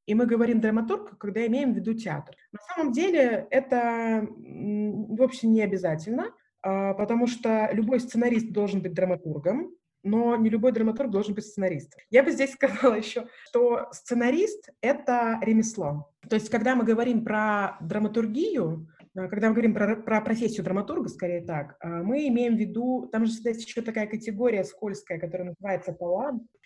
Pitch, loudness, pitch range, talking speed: 225 Hz, -26 LUFS, 205-245 Hz, 160 wpm